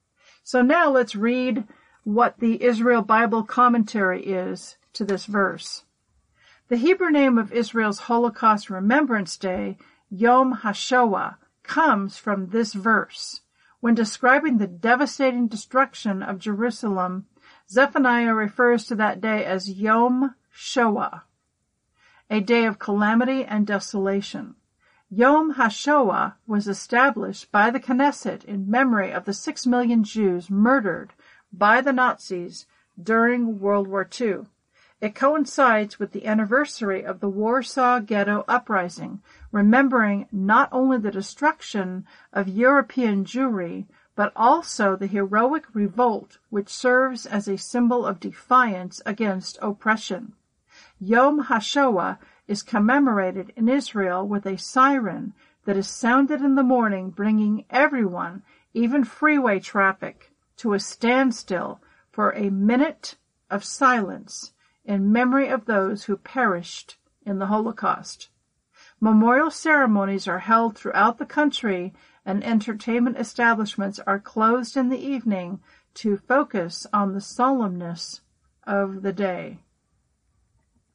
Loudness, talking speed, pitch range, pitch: -22 LUFS, 120 wpm, 200-255 Hz, 225 Hz